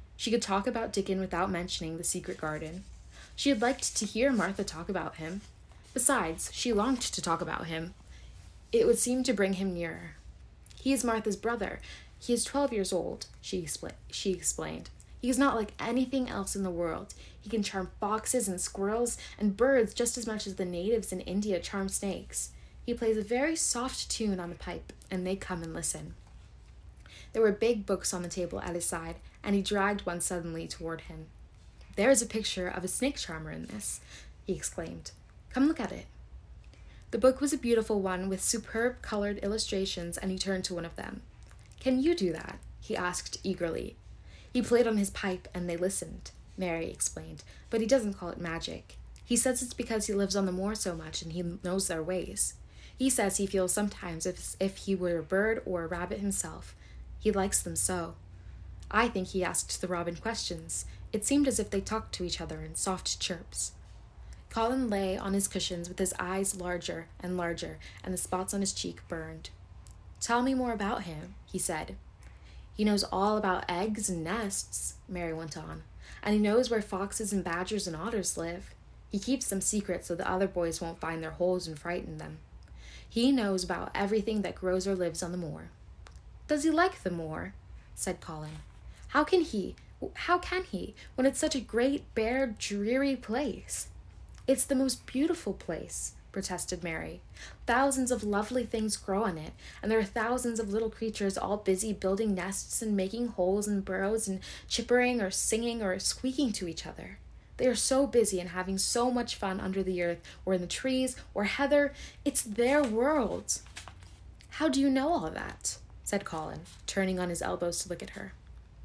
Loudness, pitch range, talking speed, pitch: -31 LUFS, 175-230 Hz, 190 wpm, 195 Hz